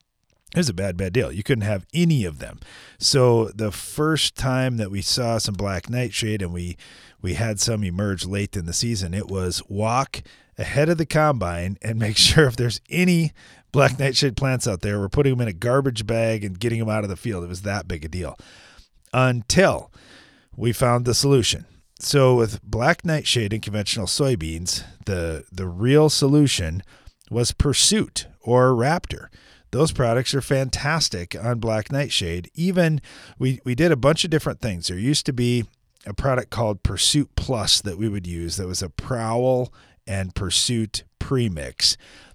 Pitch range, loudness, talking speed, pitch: 95-130 Hz, -22 LUFS, 180 wpm, 115 Hz